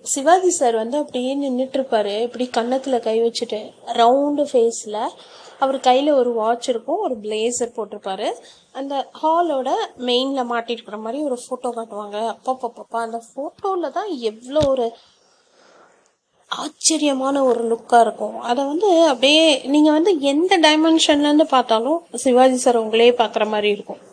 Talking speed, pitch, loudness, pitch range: 130 wpm, 255 Hz, -19 LUFS, 230-295 Hz